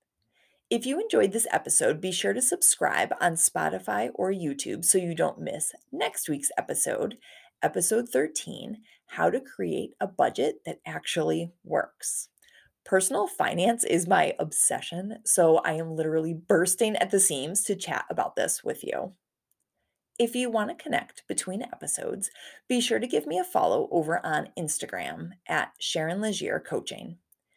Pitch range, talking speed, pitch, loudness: 165-230 Hz, 150 wpm, 185 Hz, -27 LUFS